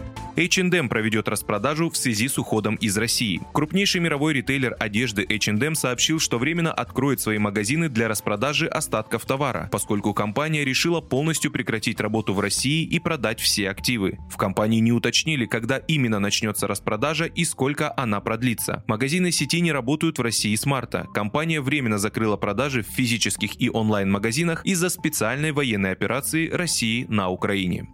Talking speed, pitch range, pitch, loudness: 155 wpm, 110-150 Hz, 120 Hz, -23 LUFS